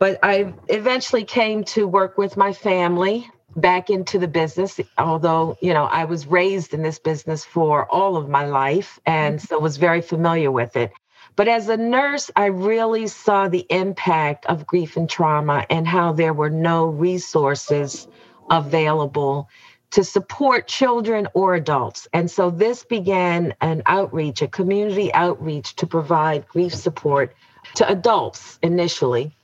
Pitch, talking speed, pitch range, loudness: 175 Hz, 155 wpm, 160-200 Hz, -20 LUFS